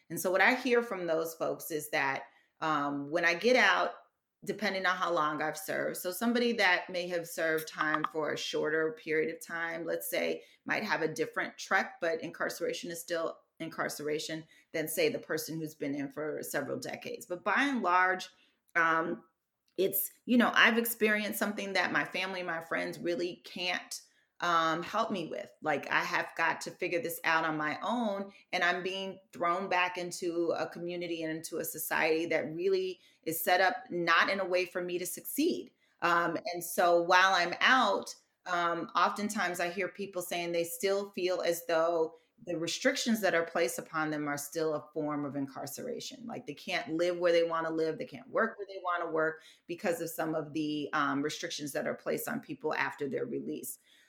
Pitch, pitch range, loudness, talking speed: 170 Hz, 160-185 Hz, -32 LUFS, 195 wpm